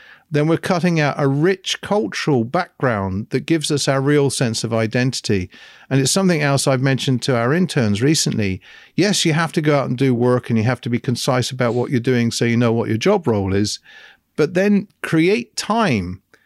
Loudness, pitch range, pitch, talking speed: -18 LUFS, 120-160 Hz, 135 Hz, 210 wpm